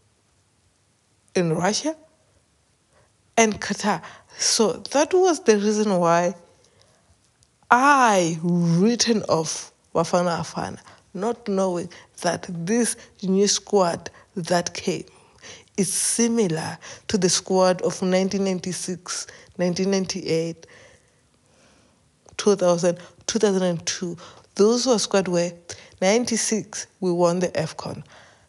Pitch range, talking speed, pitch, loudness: 175-215 Hz, 90 wpm, 185 Hz, -22 LUFS